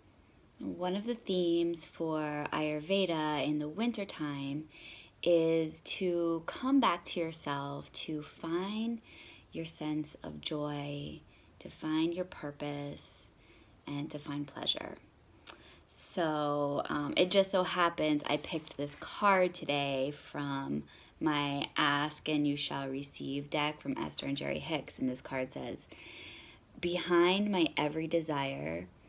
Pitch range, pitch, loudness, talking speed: 140-170 Hz, 150 Hz, -34 LUFS, 130 wpm